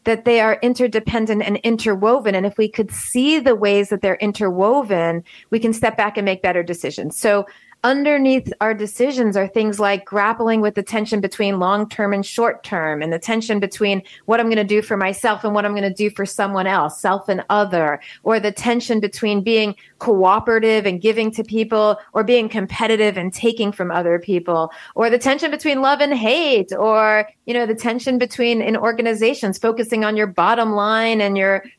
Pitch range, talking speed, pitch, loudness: 200-230 Hz, 195 wpm, 215 Hz, -18 LUFS